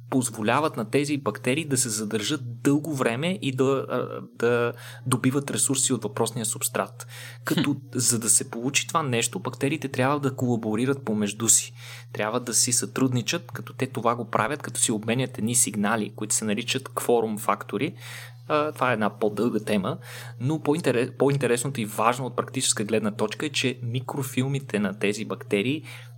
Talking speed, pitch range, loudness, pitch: 160 wpm, 115-135 Hz, -25 LUFS, 120 Hz